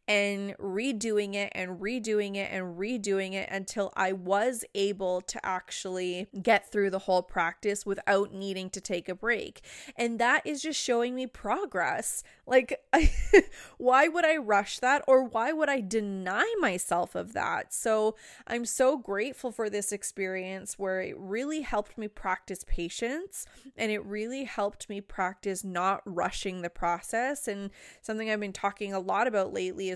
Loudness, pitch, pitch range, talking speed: -30 LUFS, 205 Hz, 190-240 Hz, 165 wpm